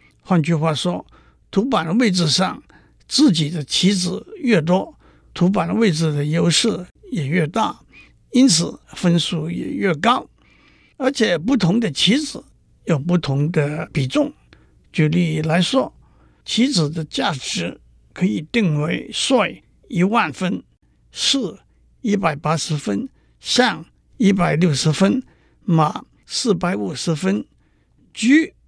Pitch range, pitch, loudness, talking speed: 160-220 Hz, 180 Hz, -19 LUFS, 175 characters per minute